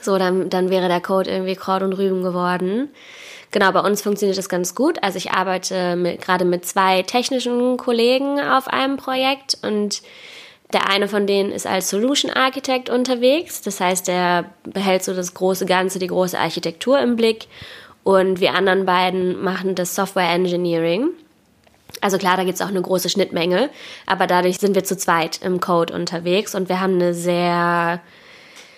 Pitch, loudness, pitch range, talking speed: 190 Hz, -19 LUFS, 180-230 Hz, 175 wpm